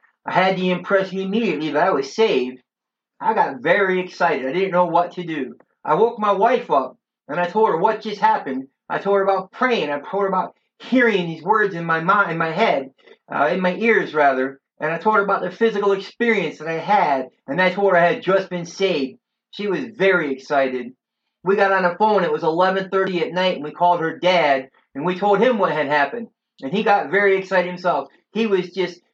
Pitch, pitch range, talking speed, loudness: 190 Hz, 170-210 Hz, 225 wpm, -19 LUFS